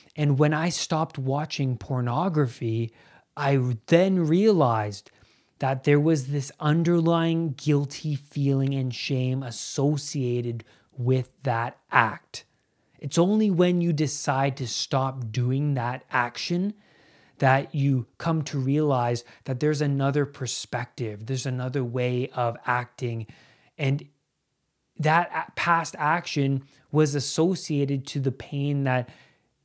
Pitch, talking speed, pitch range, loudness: 140 Hz, 115 wpm, 125-150 Hz, -25 LUFS